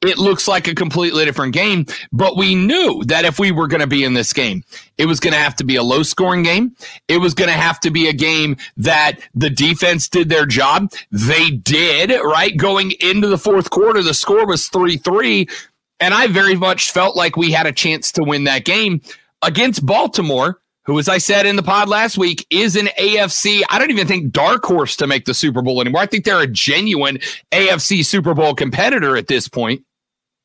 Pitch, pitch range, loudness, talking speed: 175 Hz, 150-195 Hz, -14 LUFS, 220 wpm